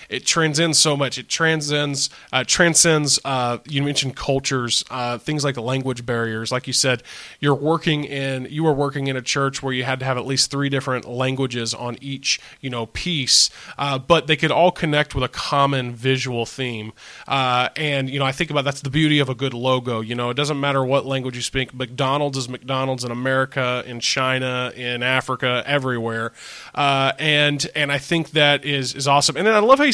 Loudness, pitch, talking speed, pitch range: -20 LUFS, 135 Hz, 205 wpm, 125-145 Hz